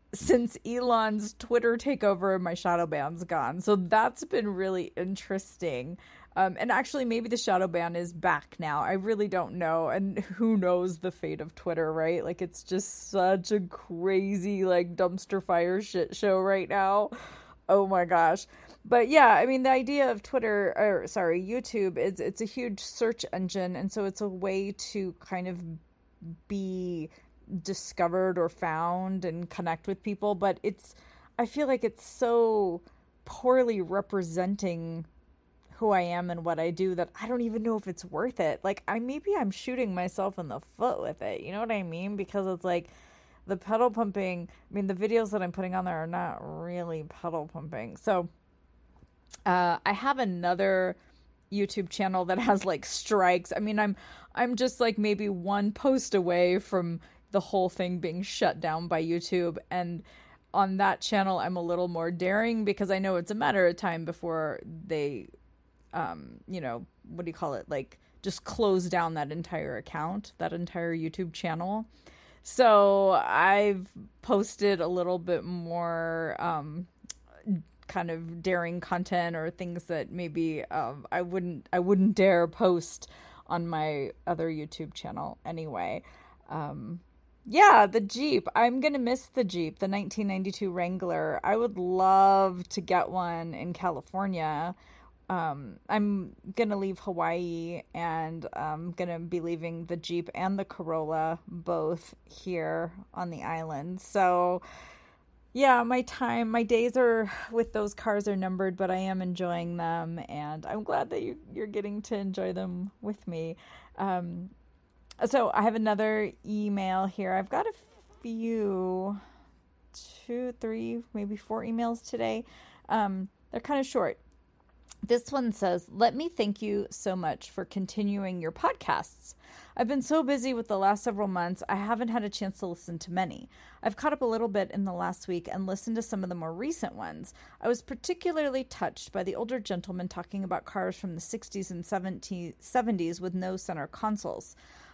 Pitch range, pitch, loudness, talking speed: 175-210 Hz, 190 Hz, -30 LUFS, 165 wpm